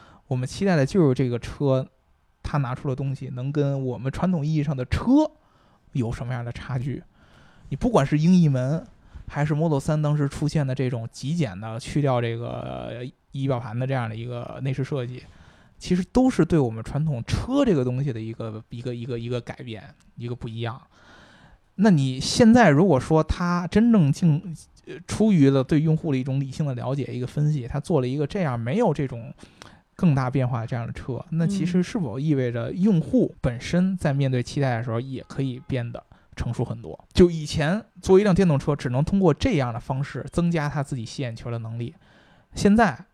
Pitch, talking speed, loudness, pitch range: 140 Hz, 300 characters per minute, -24 LUFS, 125-160 Hz